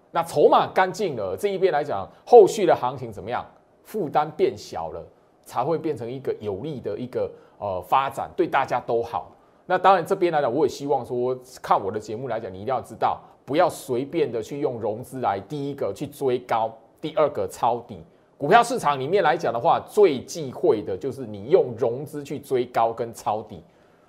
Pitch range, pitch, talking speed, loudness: 125-205 Hz, 150 Hz, 285 characters per minute, -23 LUFS